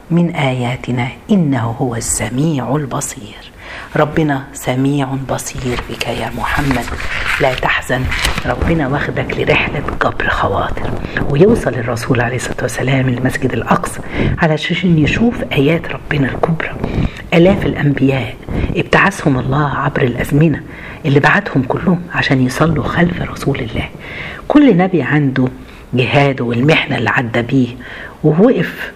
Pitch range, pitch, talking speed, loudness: 125-155 Hz, 135 Hz, 115 wpm, -15 LUFS